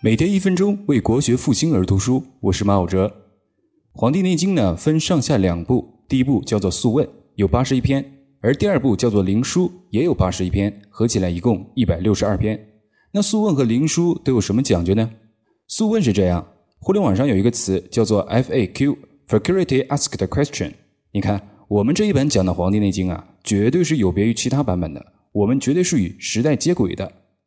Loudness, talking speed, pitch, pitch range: -19 LUFS, 335 characters per minute, 115 Hz, 100-140 Hz